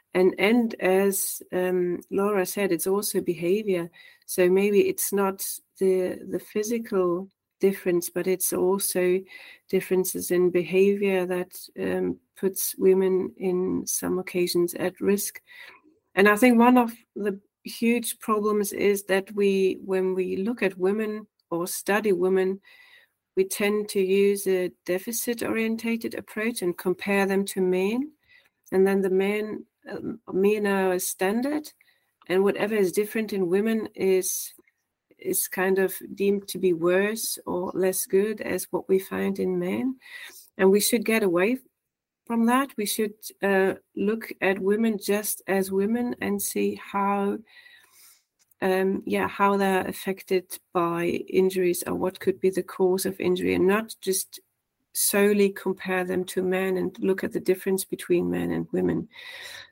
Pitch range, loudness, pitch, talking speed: 185-210 Hz, -25 LUFS, 195 Hz, 145 wpm